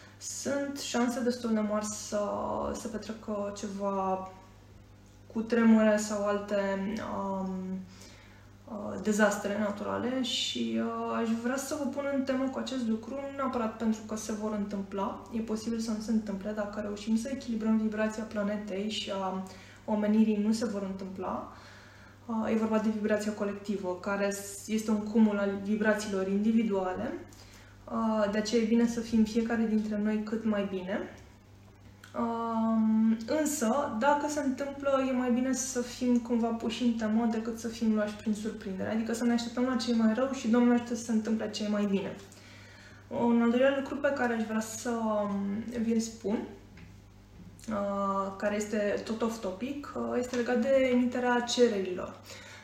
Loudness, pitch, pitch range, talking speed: -31 LUFS, 215 Hz, 195-235 Hz, 160 wpm